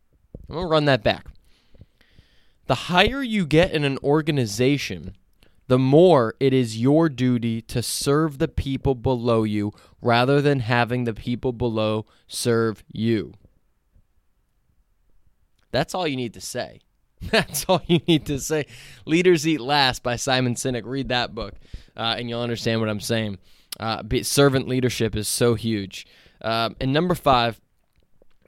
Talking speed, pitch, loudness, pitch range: 150 wpm, 125 Hz, -22 LUFS, 115-145 Hz